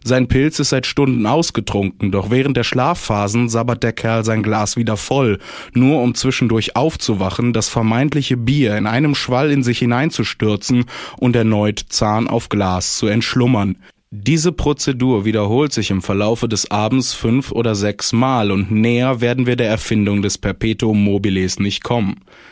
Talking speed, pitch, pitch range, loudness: 160 wpm, 115 Hz, 105-130 Hz, -16 LUFS